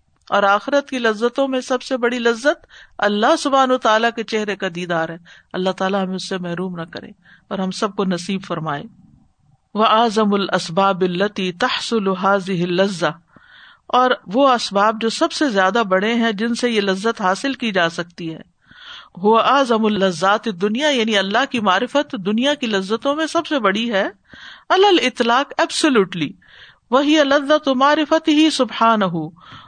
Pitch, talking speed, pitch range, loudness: 220 Hz, 150 wpm, 190-260 Hz, -18 LUFS